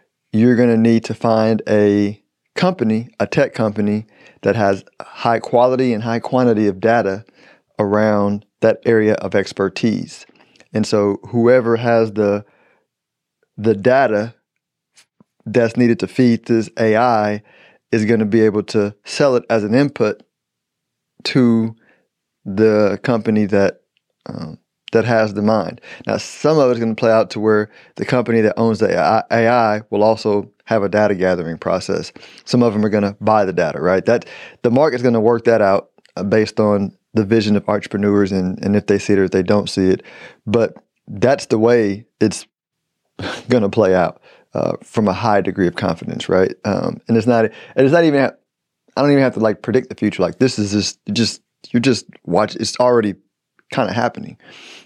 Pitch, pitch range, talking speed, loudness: 110 Hz, 105-115 Hz, 175 wpm, -17 LUFS